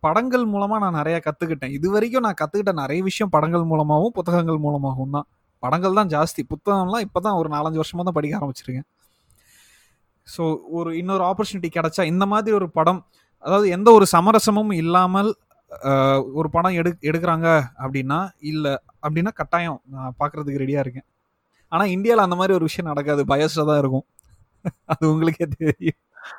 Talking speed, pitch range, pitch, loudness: 150 wpm, 150-190 Hz, 165 Hz, -20 LUFS